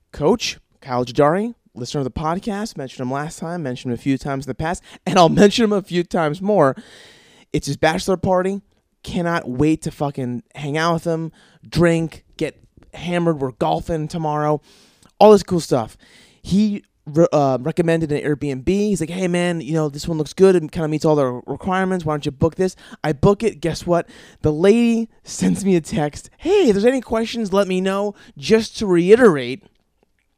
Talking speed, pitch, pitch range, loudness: 195 wpm, 165 Hz, 150-195 Hz, -19 LUFS